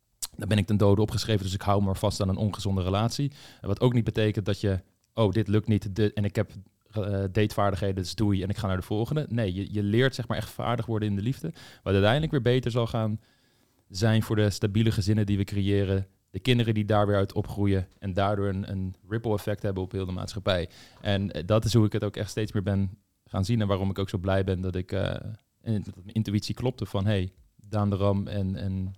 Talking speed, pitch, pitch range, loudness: 245 wpm, 105 Hz, 100-110 Hz, -28 LUFS